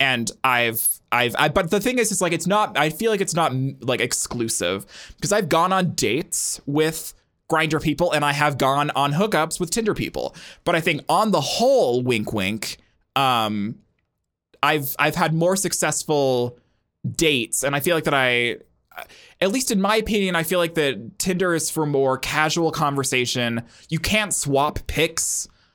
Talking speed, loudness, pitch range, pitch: 175 wpm, -21 LUFS, 130-180 Hz, 155 Hz